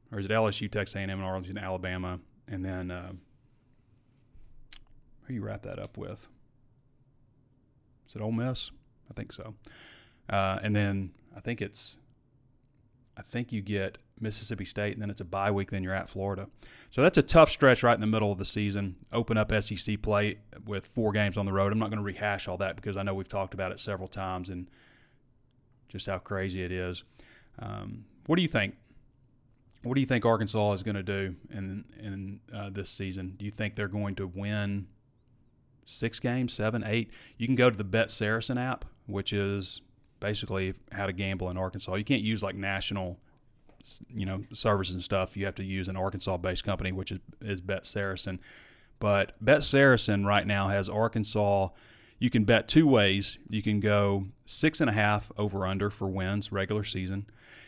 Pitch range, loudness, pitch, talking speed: 95-120 Hz, -30 LUFS, 105 Hz, 195 wpm